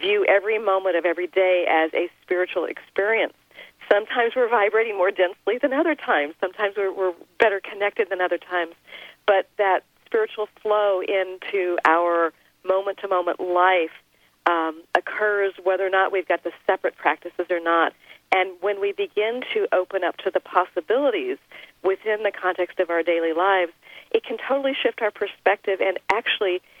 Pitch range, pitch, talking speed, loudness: 180-205 Hz, 190 Hz, 165 wpm, -22 LUFS